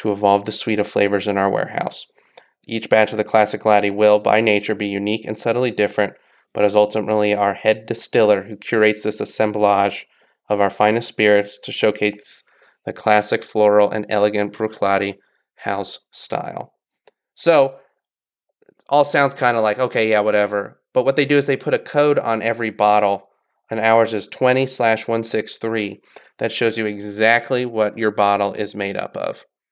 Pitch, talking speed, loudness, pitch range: 105 Hz, 170 wpm, -18 LUFS, 105-115 Hz